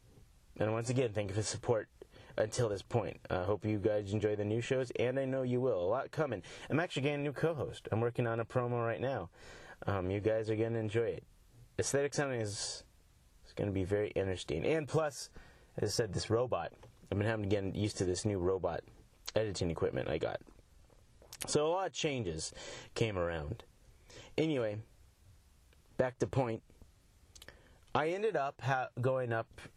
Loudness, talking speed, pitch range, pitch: -36 LUFS, 190 wpm, 100-125 Hz, 110 Hz